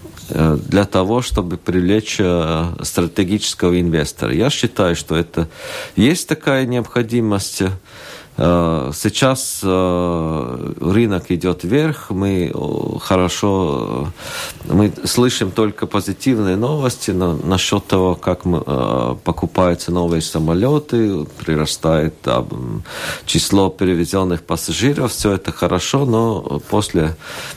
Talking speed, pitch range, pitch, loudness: 85 wpm, 85-105 Hz, 95 Hz, -17 LUFS